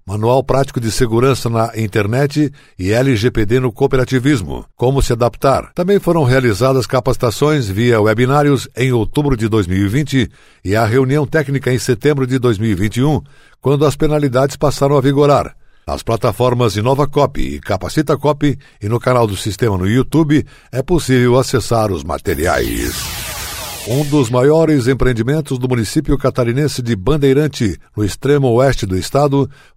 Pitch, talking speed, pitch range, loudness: 130 Hz, 140 wpm, 115-140 Hz, -15 LUFS